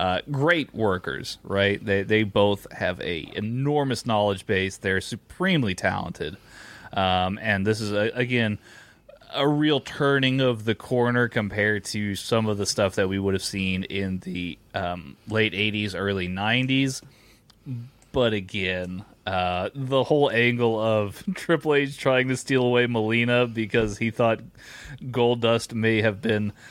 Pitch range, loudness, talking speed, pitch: 100-125 Hz, -24 LUFS, 150 wpm, 110 Hz